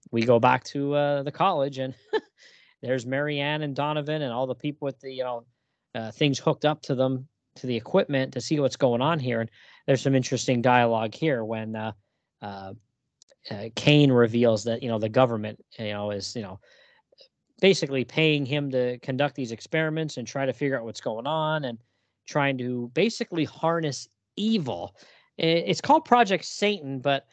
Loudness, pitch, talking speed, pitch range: -25 LUFS, 135 Hz, 180 wpm, 120-150 Hz